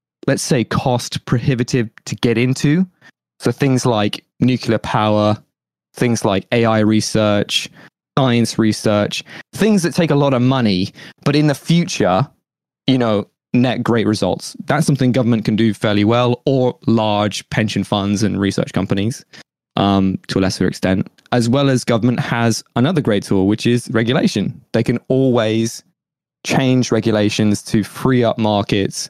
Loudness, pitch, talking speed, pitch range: -17 LUFS, 120 Hz, 150 wpm, 105-130 Hz